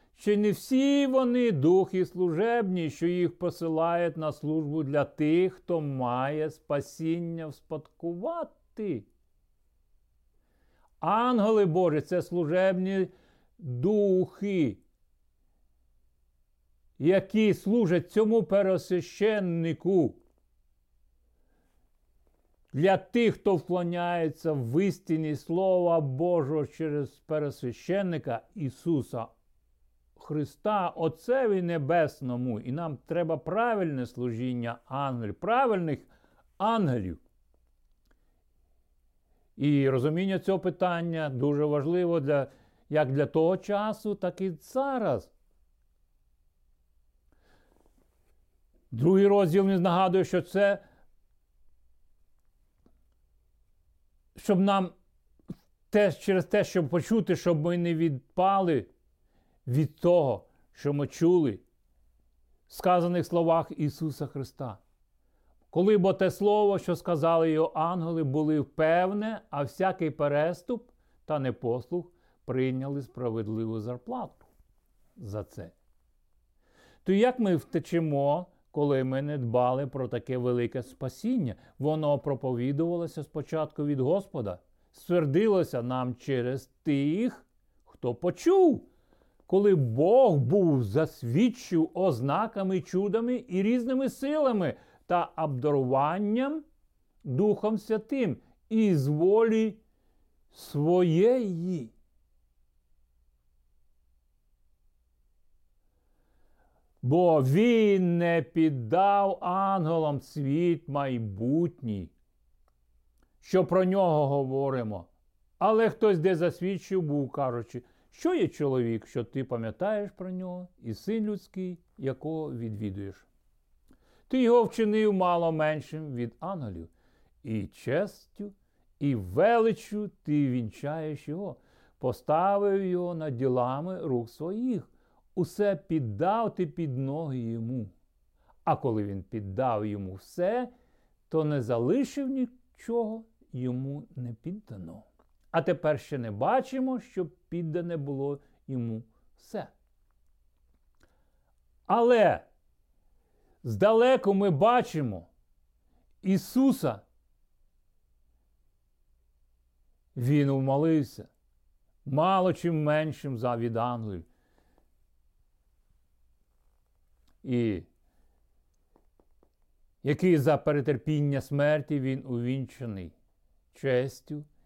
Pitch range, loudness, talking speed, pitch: 110-185 Hz, -28 LUFS, 85 wpm, 150 Hz